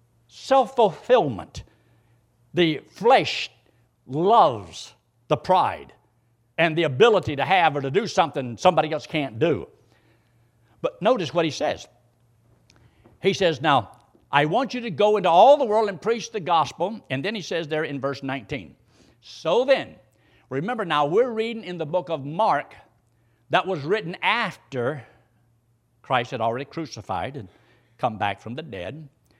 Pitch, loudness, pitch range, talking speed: 140 Hz, -23 LUFS, 115-180 Hz, 150 wpm